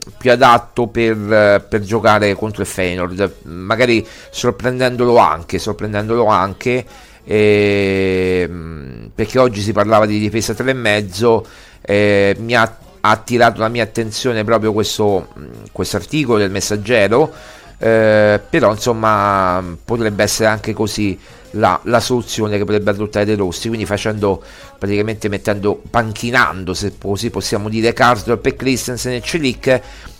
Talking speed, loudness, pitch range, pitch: 125 wpm, -15 LUFS, 100-115 Hz, 105 Hz